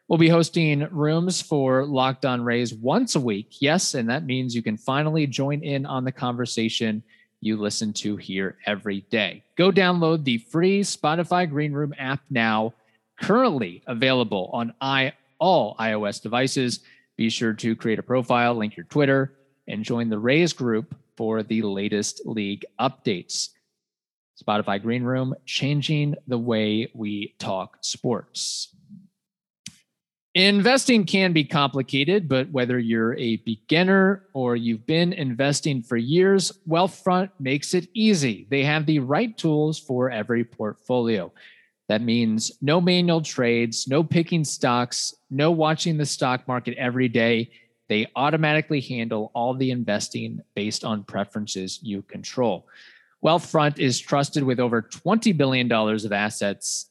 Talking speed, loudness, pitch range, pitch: 140 wpm, -23 LUFS, 115-155 Hz, 130 Hz